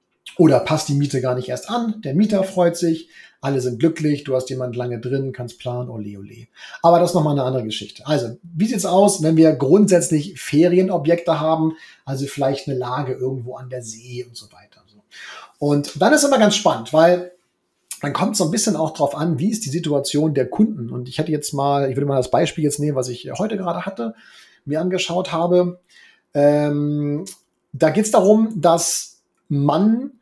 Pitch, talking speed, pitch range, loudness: 150 Hz, 205 wpm, 130-175 Hz, -19 LUFS